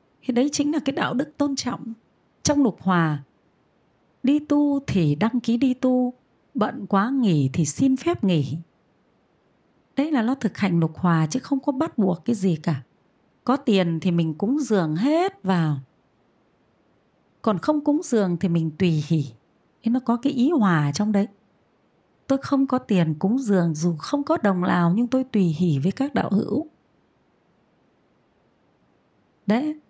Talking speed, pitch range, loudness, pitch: 170 wpm, 175-270 Hz, -23 LUFS, 215 Hz